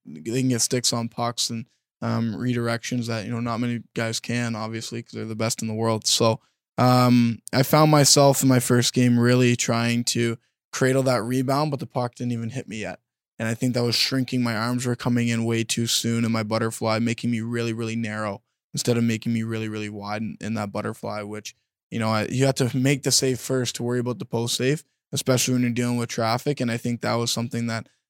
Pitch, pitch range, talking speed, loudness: 120 Hz, 115-125 Hz, 235 wpm, -23 LUFS